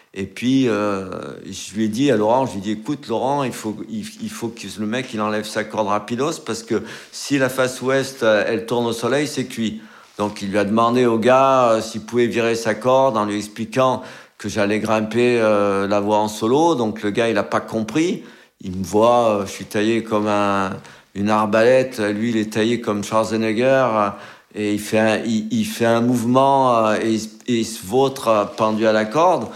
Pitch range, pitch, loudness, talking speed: 105-125 Hz, 110 Hz, -19 LUFS, 215 wpm